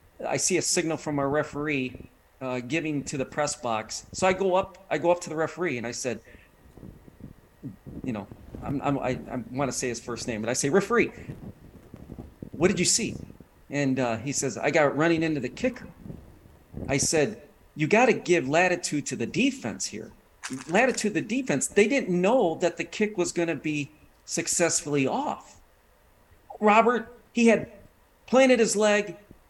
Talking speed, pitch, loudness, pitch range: 175 wpm, 150 Hz, -26 LUFS, 125-185 Hz